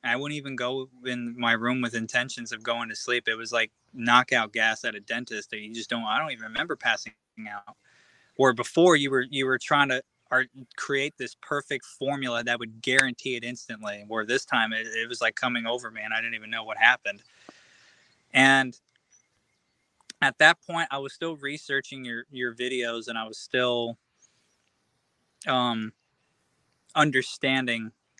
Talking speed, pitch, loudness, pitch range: 175 wpm, 125 Hz, -26 LUFS, 115-135 Hz